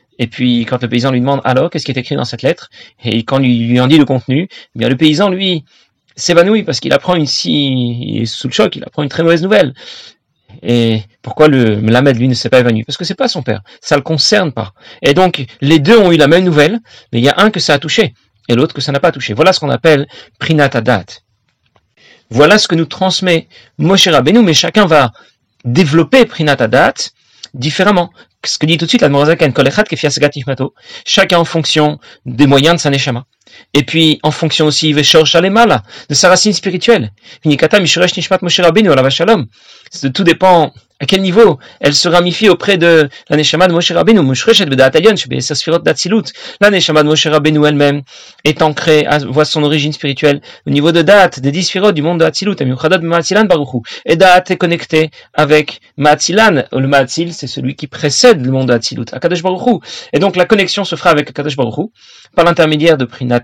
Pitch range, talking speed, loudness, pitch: 135-175 Hz, 200 wpm, -11 LUFS, 155 Hz